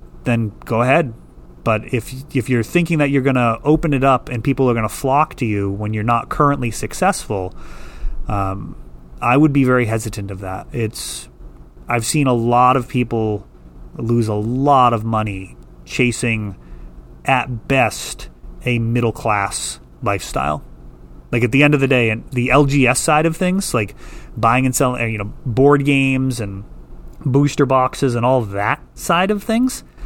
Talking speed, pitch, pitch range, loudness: 170 wpm, 120 Hz, 100-135 Hz, -17 LUFS